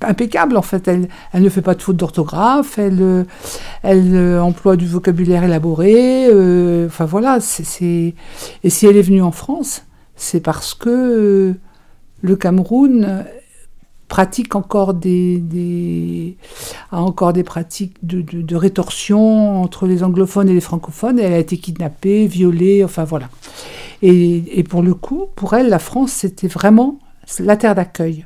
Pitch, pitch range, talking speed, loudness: 185 Hz, 175-205 Hz, 160 wpm, -14 LUFS